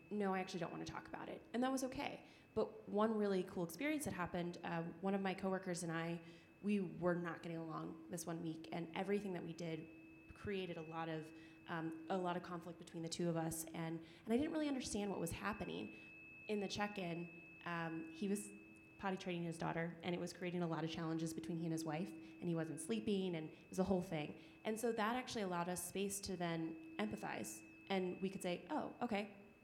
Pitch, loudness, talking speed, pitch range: 175 Hz, -44 LUFS, 230 wpm, 165-195 Hz